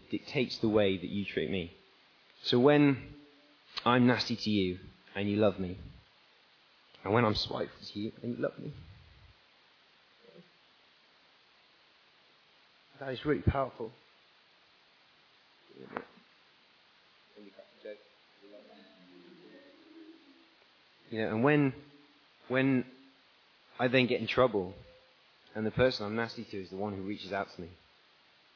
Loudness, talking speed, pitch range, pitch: -31 LUFS, 120 wpm, 105-140 Hz, 120 Hz